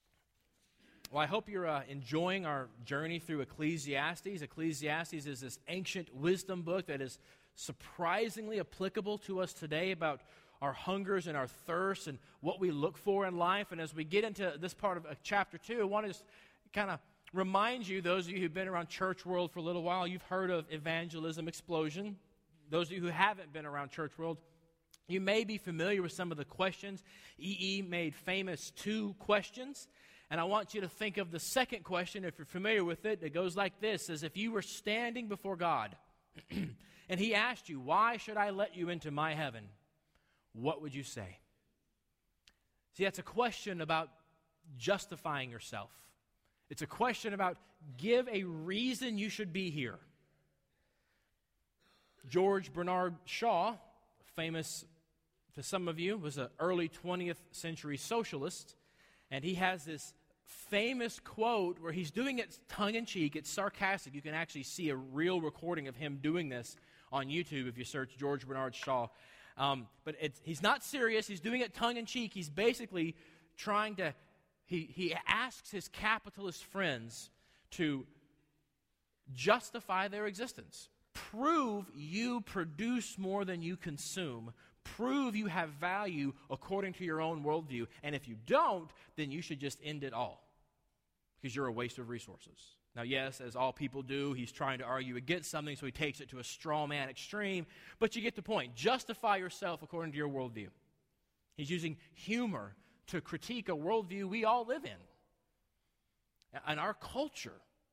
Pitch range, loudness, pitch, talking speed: 150-200 Hz, -38 LUFS, 175 Hz, 170 wpm